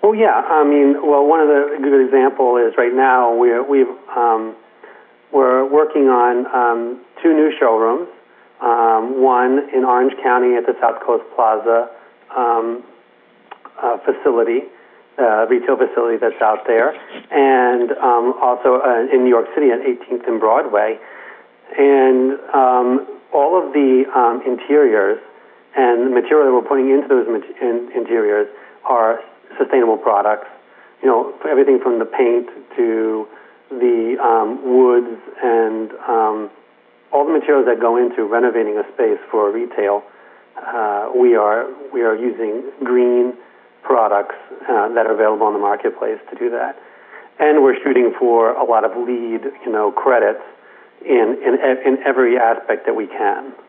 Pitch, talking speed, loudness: 155 Hz, 150 wpm, -16 LUFS